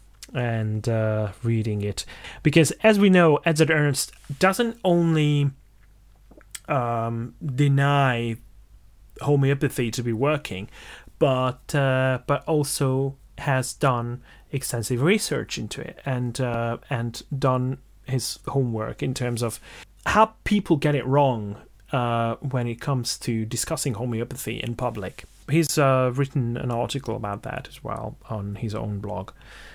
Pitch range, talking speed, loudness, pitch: 115-140 Hz, 130 wpm, -24 LUFS, 125 Hz